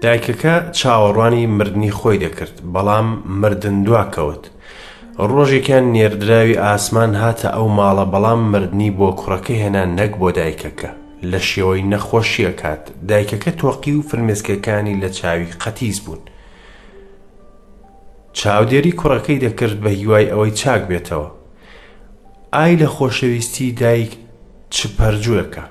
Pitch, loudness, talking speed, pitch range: 105 Hz, -16 LUFS, 110 wpm, 100-115 Hz